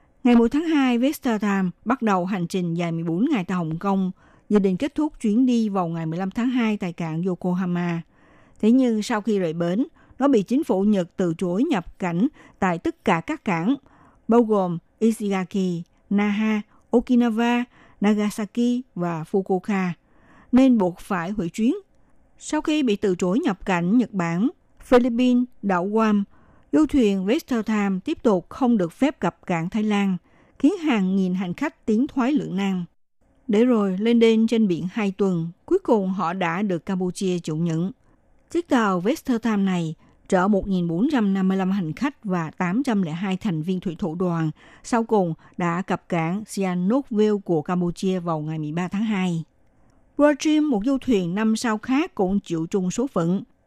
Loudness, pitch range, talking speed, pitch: -23 LUFS, 180-240 Hz, 170 wpm, 205 Hz